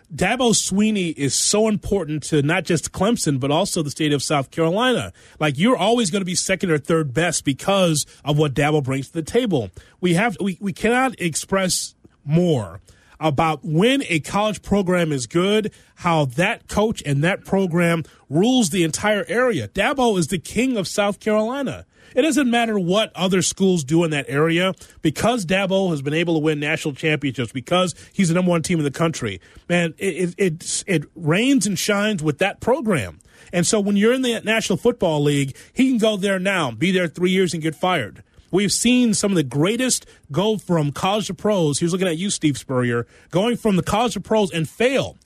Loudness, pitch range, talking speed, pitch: -20 LUFS, 155-210 Hz, 200 wpm, 180 Hz